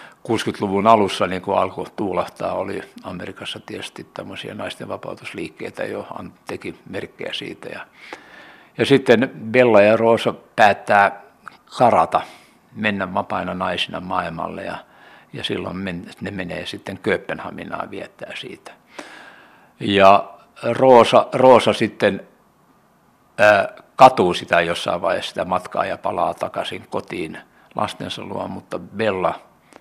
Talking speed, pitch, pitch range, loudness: 115 wpm, 100 Hz, 95-110 Hz, -19 LUFS